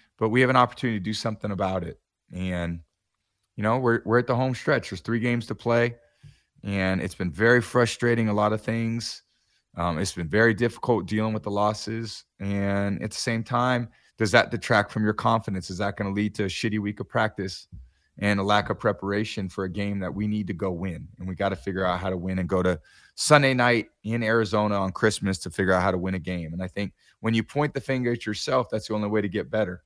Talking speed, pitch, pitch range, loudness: 245 wpm, 105 Hz, 95-115 Hz, -25 LUFS